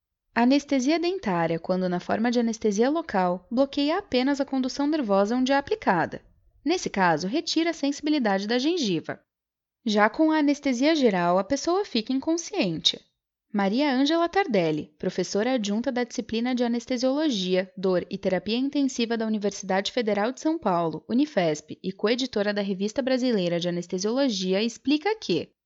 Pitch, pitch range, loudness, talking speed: 240 Hz, 195-280 Hz, -25 LUFS, 145 wpm